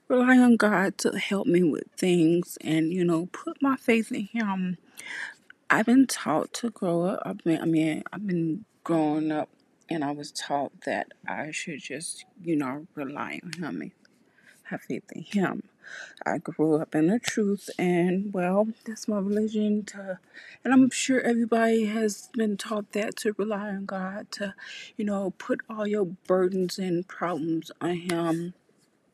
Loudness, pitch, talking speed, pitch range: -27 LUFS, 195 Hz, 170 wpm, 170-220 Hz